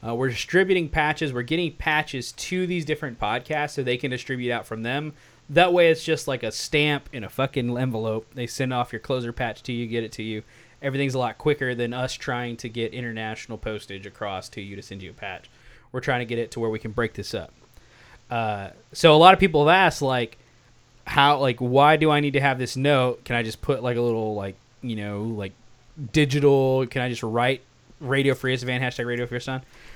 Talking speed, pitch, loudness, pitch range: 230 wpm, 125 Hz, -23 LUFS, 115-140 Hz